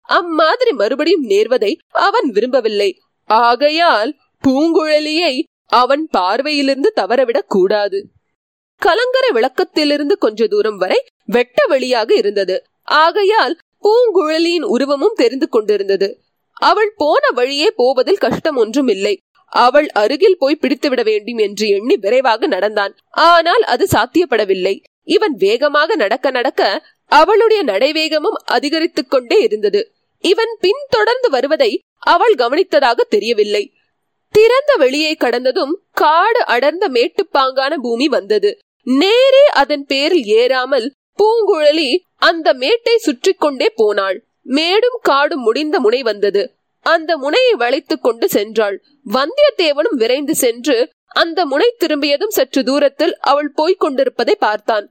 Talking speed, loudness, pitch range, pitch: 105 wpm, -14 LUFS, 280-420 Hz, 330 Hz